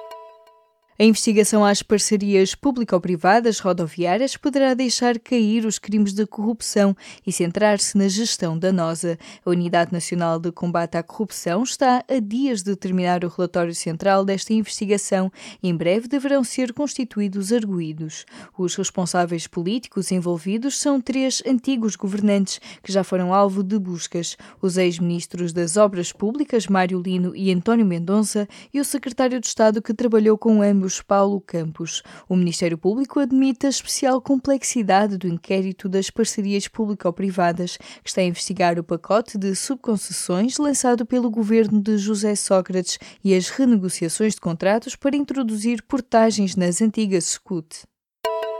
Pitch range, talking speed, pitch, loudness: 180-230 Hz, 140 wpm, 200 Hz, -21 LUFS